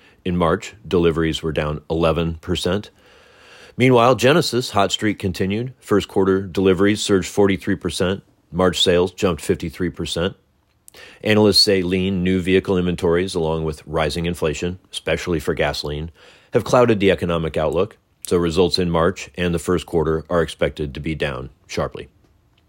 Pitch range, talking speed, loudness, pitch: 85-100 Hz, 140 wpm, -19 LUFS, 90 Hz